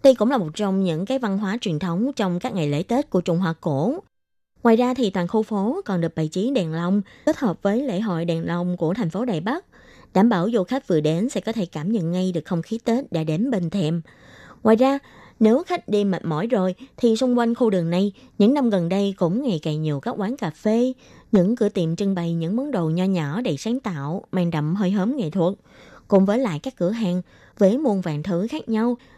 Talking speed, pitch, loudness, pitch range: 250 wpm, 200 Hz, -22 LUFS, 175-235 Hz